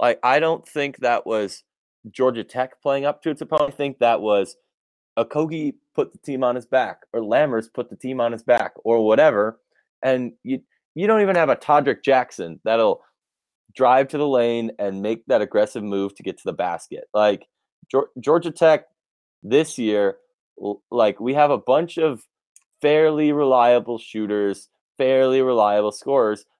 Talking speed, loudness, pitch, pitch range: 170 wpm, -21 LUFS, 130 Hz, 110-150 Hz